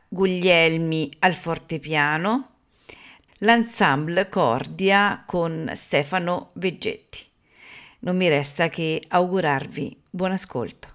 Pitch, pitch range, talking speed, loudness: 180 Hz, 160-195 Hz, 80 wpm, -22 LUFS